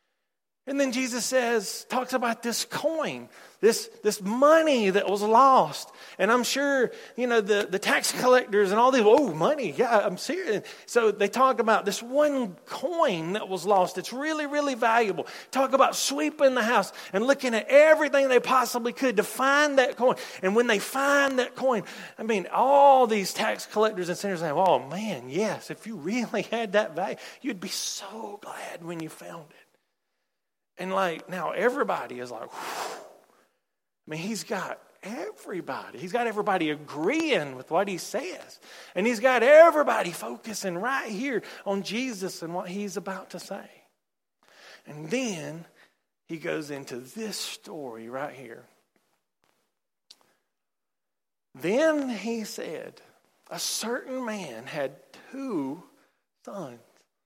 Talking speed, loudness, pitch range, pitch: 155 wpm, -25 LUFS, 195-265 Hz, 230 Hz